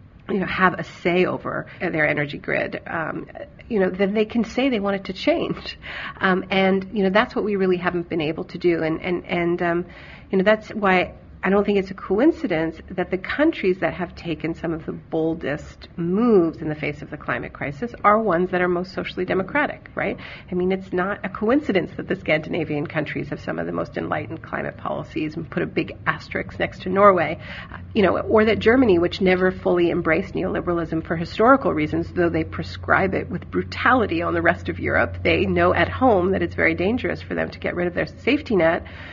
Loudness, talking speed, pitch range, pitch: -22 LUFS, 215 wpm, 160-200 Hz, 180 Hz